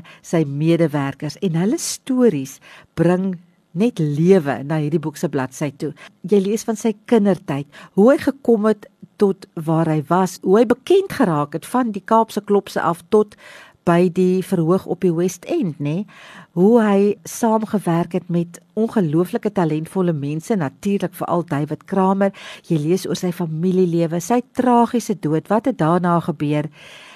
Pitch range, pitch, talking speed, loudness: 165-210 Hz, 180 Hz, 155 wpm, -19 LUFS